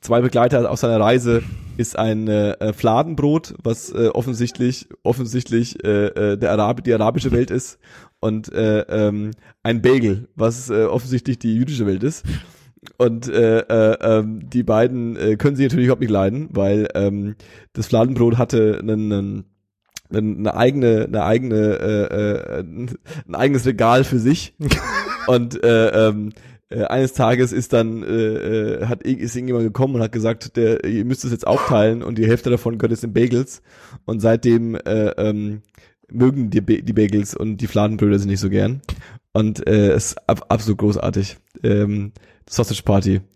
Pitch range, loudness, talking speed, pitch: 105-120 Hz, -19 LUFS, 165 wpm, 115 Hz